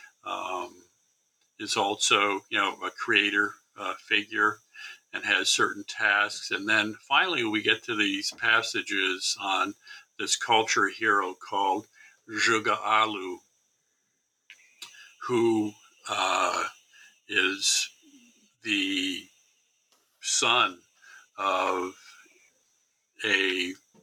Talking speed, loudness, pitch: 85 wpm, -26 LUFS, 300 Hz